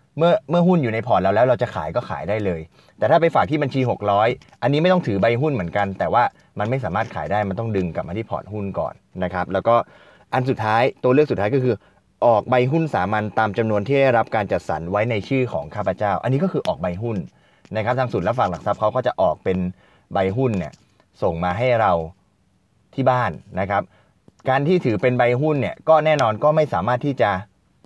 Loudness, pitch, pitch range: -20 LUFS, 115 Hz, 95-130 Hz